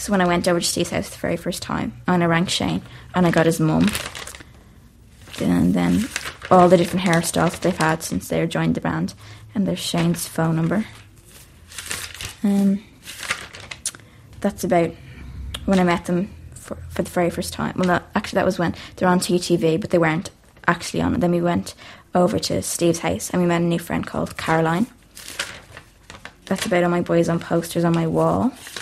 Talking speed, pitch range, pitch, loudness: 195 wpm, 160-180 Hz, 170 Hz, -21 LUFS